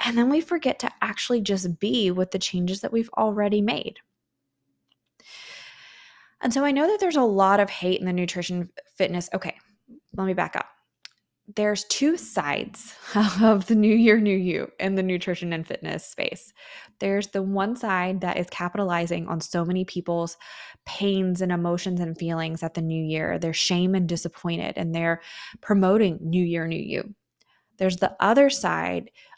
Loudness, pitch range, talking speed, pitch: -24 LUFS, 175-210 Hz, 170 wpm, 190 Hz